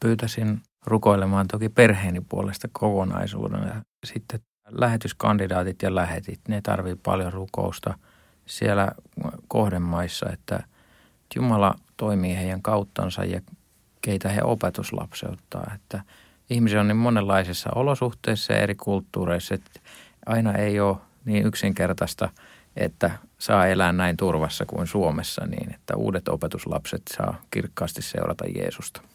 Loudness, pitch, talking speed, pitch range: -25 LUFS, 105 Hz, 115 wpm, 95-110 Hz